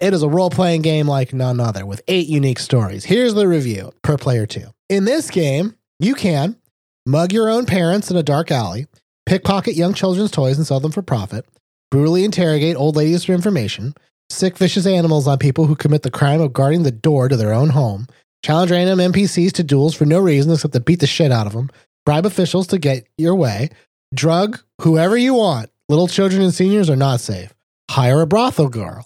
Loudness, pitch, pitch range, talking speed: -16 LUFS, 155 Hz, 135-185 Hz, 210 wpm